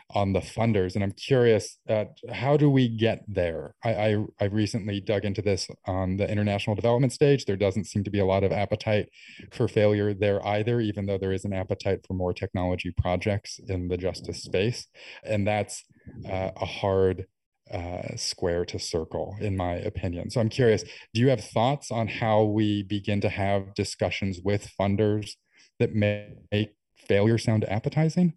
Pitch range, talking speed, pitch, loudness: 95-110 Hz, 180 wpm, 105 Hz, -27 LUFS